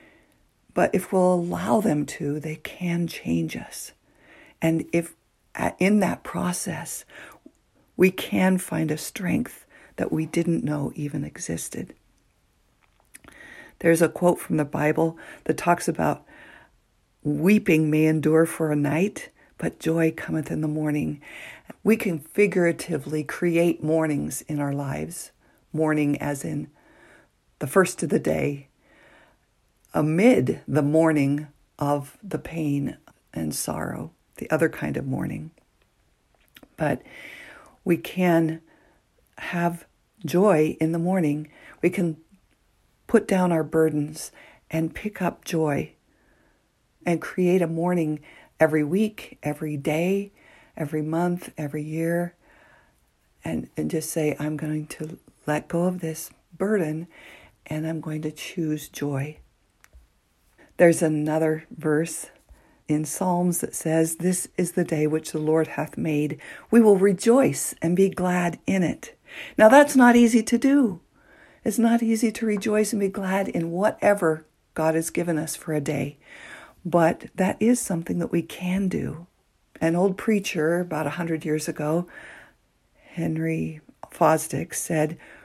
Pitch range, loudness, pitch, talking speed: 155-180 Hz, -24 LUFS, 160 Hz, 135 wpm